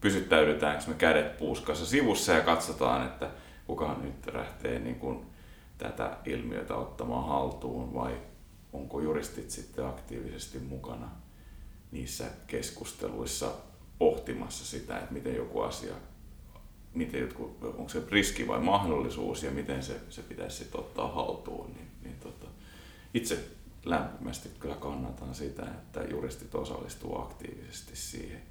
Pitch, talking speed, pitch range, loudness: 70 Hz, 120 wpm, 65-75 Hz, -33 LUFS